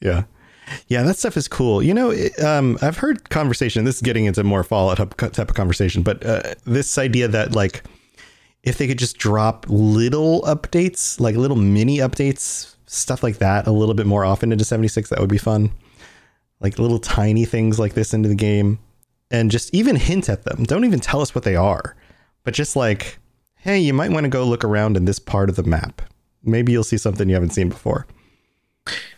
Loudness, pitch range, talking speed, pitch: -19 LUFS, 105-130 Hz, 205 wpm, 115 Hz